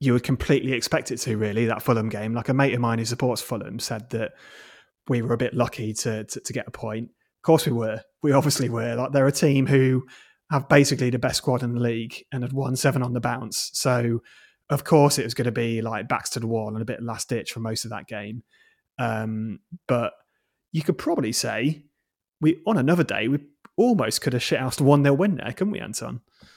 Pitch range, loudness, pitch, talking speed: 115-140 Hz, -24 LUFS, 125 Hz, 235 wpm